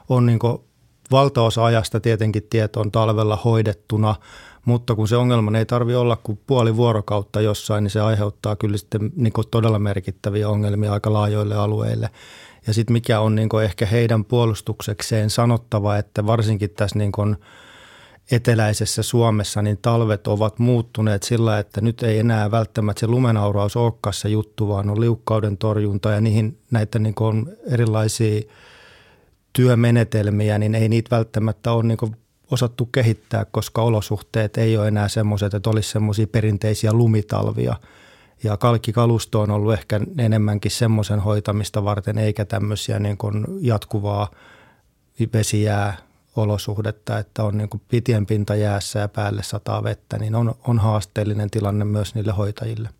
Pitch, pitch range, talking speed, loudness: 110 Hz, 105-115 Hz, 145 wpm, -20 LUFS